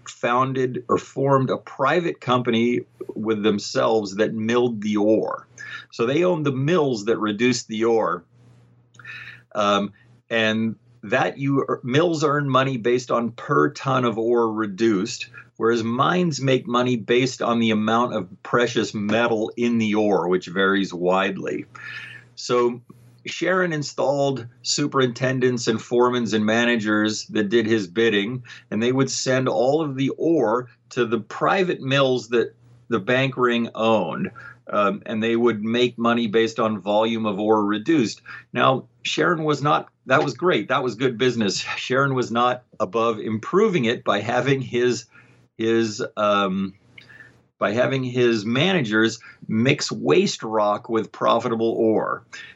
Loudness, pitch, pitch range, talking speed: -21 LUFS, 120 Hz, 110-125 Hz, 145 wpm